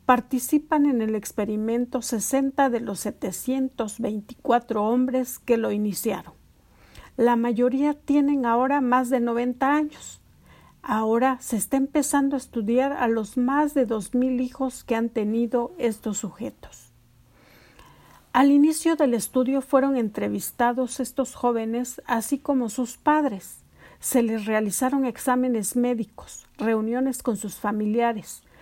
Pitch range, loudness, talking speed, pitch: 225-265 Hz, -24 LUFS, 120 wpm, 245 Hz